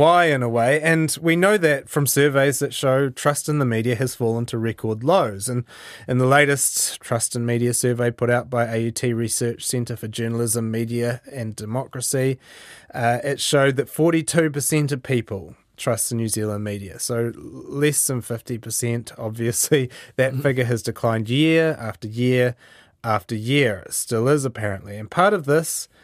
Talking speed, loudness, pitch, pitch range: 170 wpm, -21 LUFS, 125 Hz, 115-140 Hz